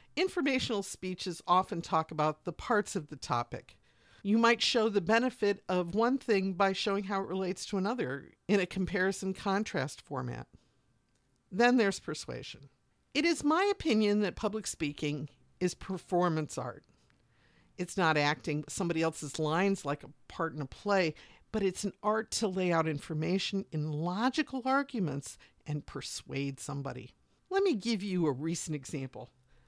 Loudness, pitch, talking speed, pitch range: -32 LUFS, 185 Hz, 155 wpm, 150-210 Hz